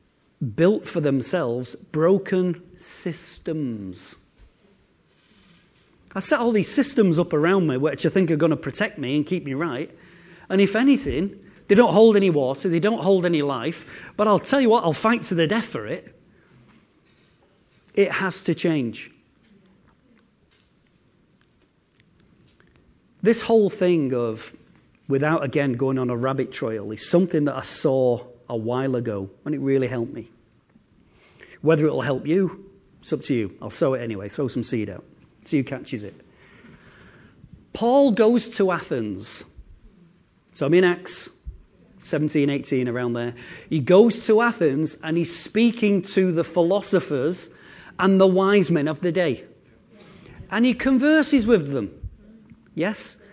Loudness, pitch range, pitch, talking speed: -22 LUFS, 135-195 Hz, 170 Hz, 150 wpm